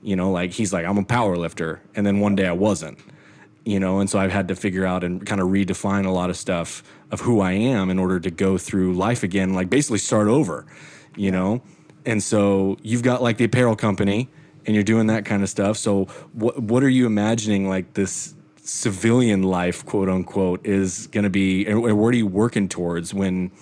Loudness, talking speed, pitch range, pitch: -21 LUFS, 220 wpm, 95-110 Hz, 100 Hz